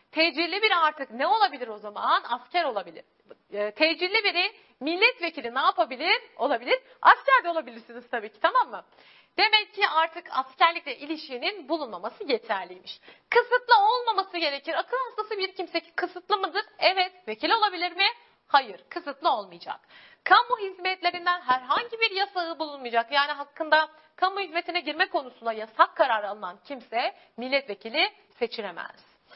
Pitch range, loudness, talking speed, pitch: 280-400 Hz, -25 LUFS, 130 wpm, 340 Hz